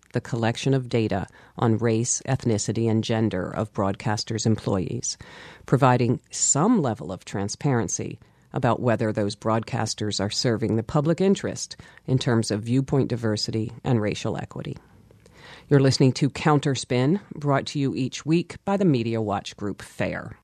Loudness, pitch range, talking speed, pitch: -24 LUFS, 110-135 Hz, 145 wpm, 115 Hz